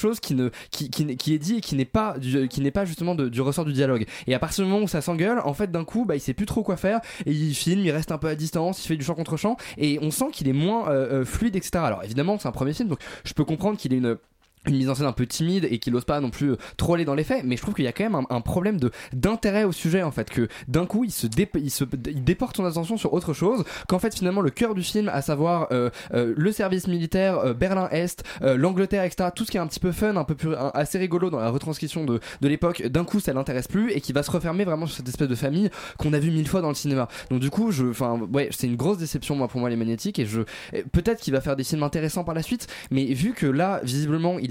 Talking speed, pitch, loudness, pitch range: 305 wpm, 155 Hz, -25 LUFS, 135-185 Hz